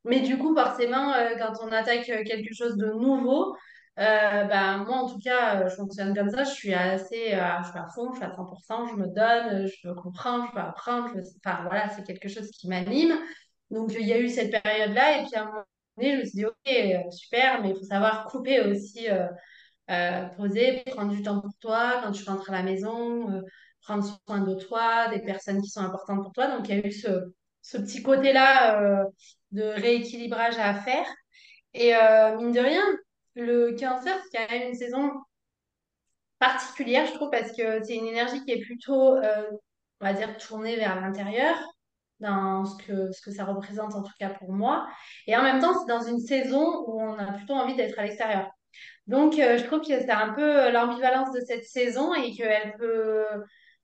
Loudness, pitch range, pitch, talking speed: -26 LUFS, 200-250 Hz, 225 Hz, 210 wpm